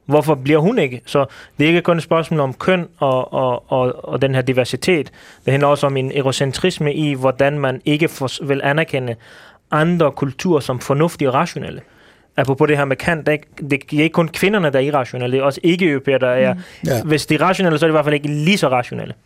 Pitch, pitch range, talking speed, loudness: 145 Hz, 135-160 Hz, 220 wpm, -17 LUFS